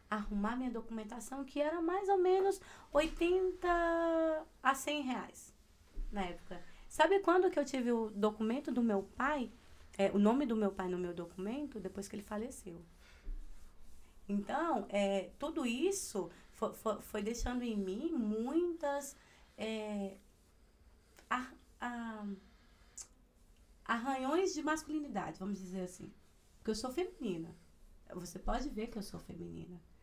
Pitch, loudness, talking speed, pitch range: 225 Hz, -37 LUFS, 135 wpm, 195-290 Hz